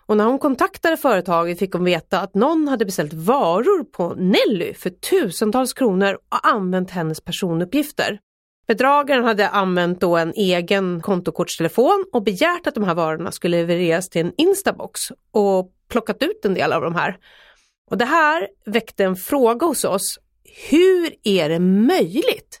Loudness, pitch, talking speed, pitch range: -19 LUFS, 210 Hz, 160 wpm, 180-280 Hz